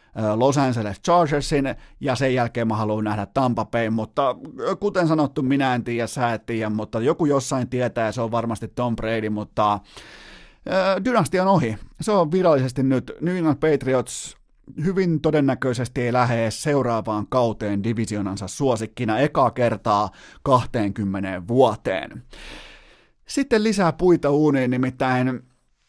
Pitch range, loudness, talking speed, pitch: 110-145 Hz, -22 LUFS, 135 wpm, 125 Hz